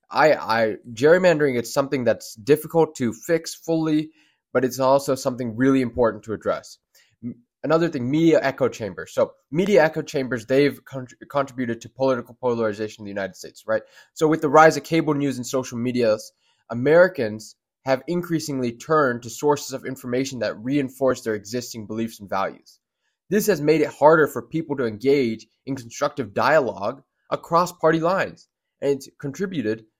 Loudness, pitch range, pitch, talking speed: -22 LUFS, 120-155 Hz, 135 Hz, 165 wpm